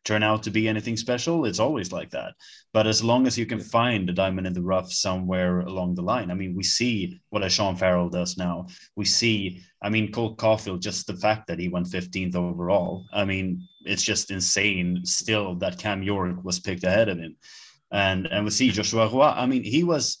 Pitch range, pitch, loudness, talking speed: 90-110 Hz, 100 Hz, -24 LUFS, 215 wpm